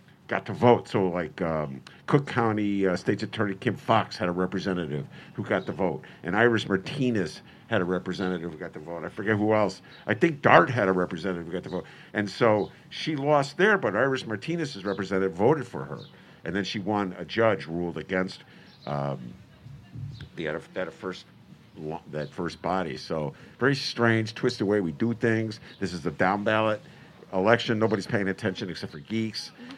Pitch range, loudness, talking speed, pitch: 90-120 Hz, -27 LUFS, 185 wpm, 105 Hz